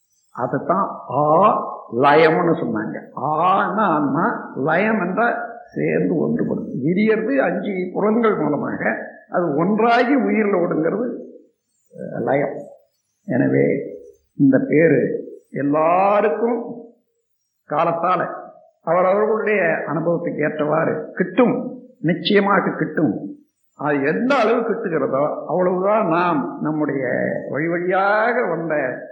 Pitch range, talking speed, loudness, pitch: 180-240 Hz, 80 wpm, -19 LUFS, 215 Hz